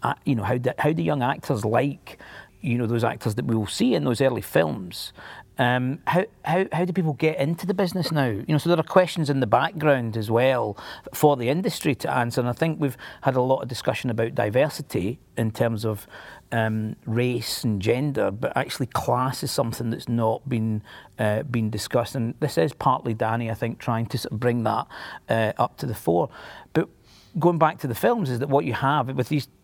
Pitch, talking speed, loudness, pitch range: 125 Hz, 220 wpm, -24 LUFS, 115-150 Hz